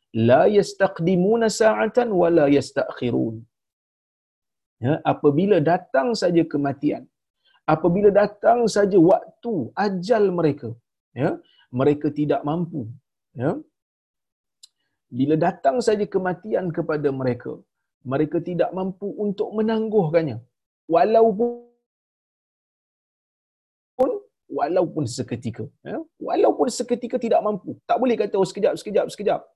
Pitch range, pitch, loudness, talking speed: 145-220 Hz, 180 Hz, -21 LUFS, 95 wpm